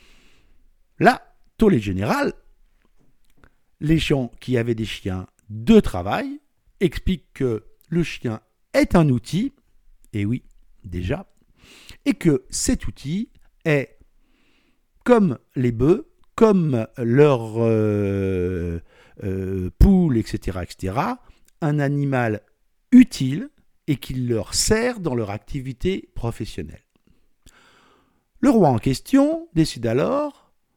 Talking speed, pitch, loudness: 105 wpm, 135 Hz, -21 LUFS